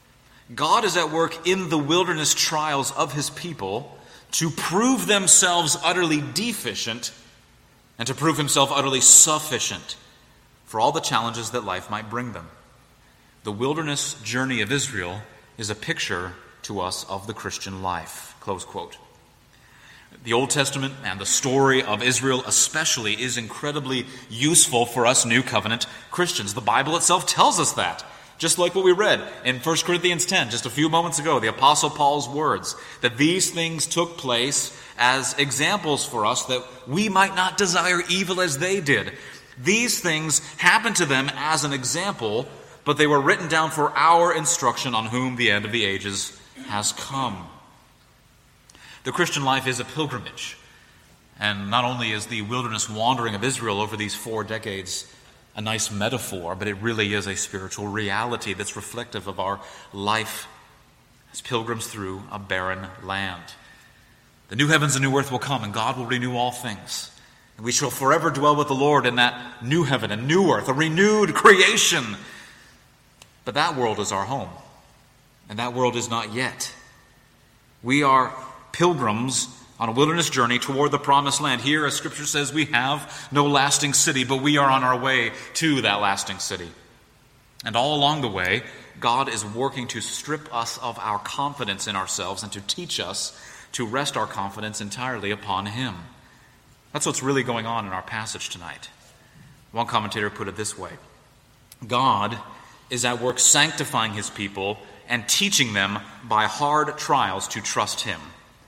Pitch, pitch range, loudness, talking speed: 130 Hz, 110-150 Hz, -22 LUFS, 165 wpm